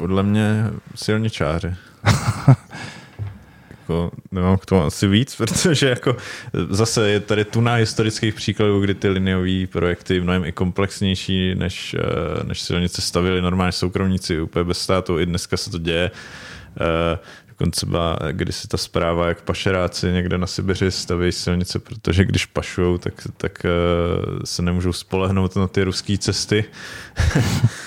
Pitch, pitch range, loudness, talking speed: 95 Hz, 90-105 Hz, -20 LUFS, 140 wpm